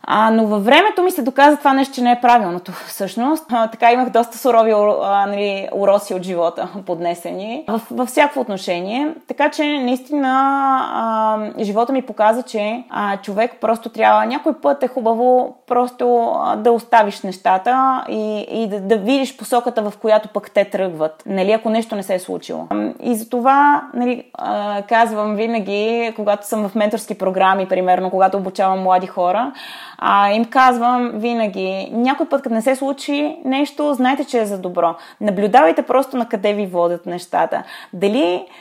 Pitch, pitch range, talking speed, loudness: 225 Hz, 200-255 Hz, 170 wpm, -17 LUFS